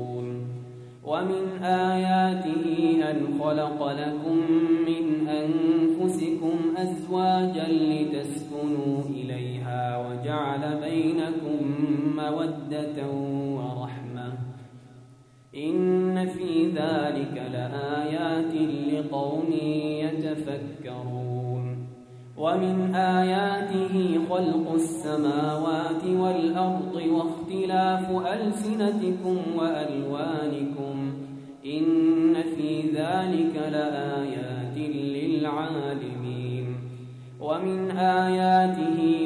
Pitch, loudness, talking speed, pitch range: 155 Hz, -26 LUFS, 55 wpm, 140-165 Hz